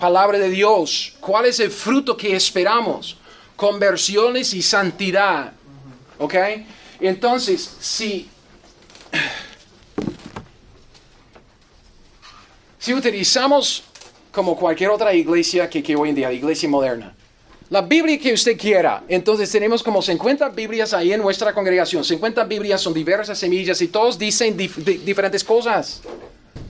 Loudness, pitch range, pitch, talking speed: -18 LUFS, 180-225 Hz, 200 Hz, 120 wpm